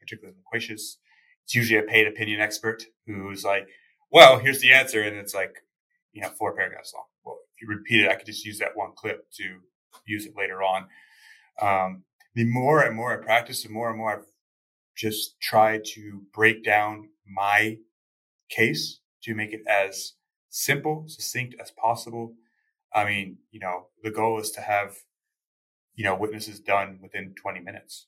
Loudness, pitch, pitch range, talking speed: -23 LUFS, 110 Hz, 100-115 Hz, 175 wpm